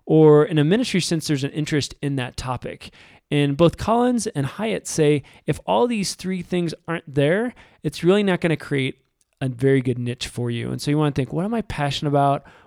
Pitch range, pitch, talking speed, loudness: 140-180 Hz, 150 Hz, 215 wpm, -21 LUFS